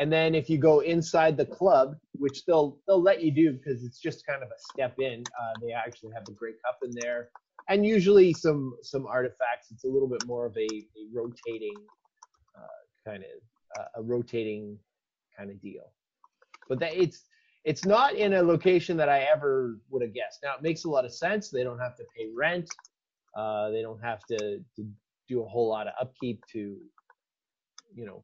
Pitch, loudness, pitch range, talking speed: 135 Hz, -27 LUFS, 115-175 Hz, 205 wpm